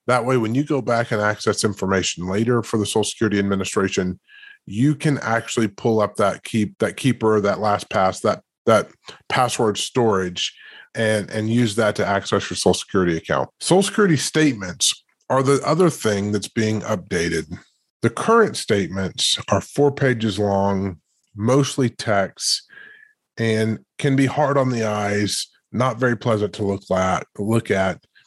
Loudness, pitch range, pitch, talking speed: -20 LUFS, 100-130 Hz, 110 Hz, 160 wpm